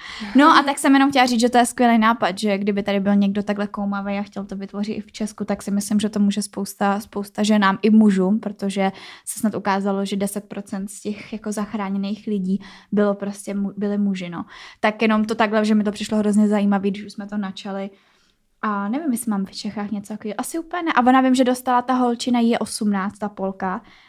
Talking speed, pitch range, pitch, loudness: 225 wpm, 200-220 Hz, 210 Hz, -21 LUFS